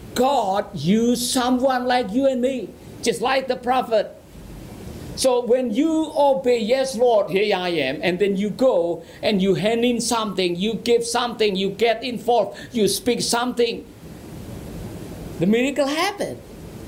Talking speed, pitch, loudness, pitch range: 145 wpm, 240 Hz, -21 LUFS, 210-255 Hz